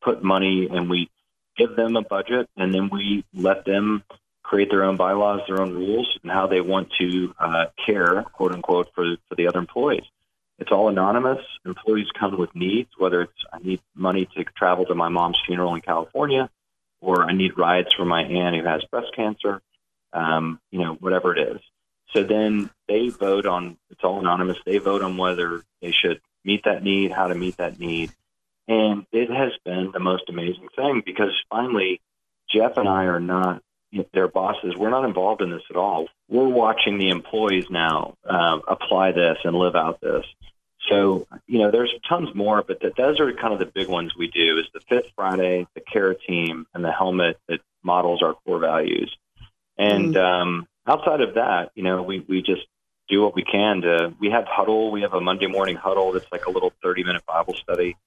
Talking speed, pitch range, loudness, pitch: 200 wpm, 90-105 Hz, -22 LUFS, 95 Hz